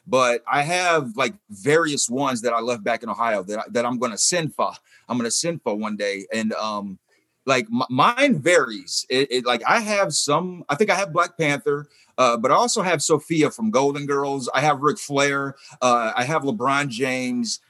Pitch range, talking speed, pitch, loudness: 125-170 Hz, 215 wpm, 145 Hz, -21 LUFS